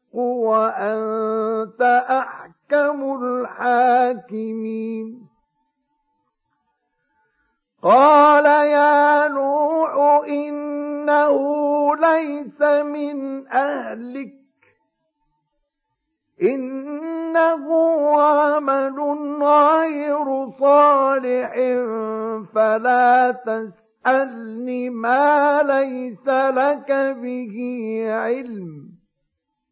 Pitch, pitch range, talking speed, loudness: 270 Hz, 235-290 Hz, 40 wpm, -18 LUFS